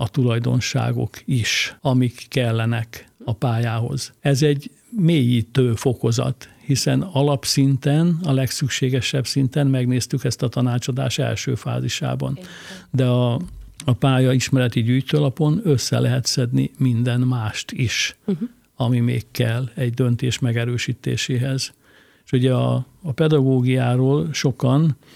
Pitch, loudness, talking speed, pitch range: 130 Hz, -20 LUFS, 110 wpm, 120-140 Hz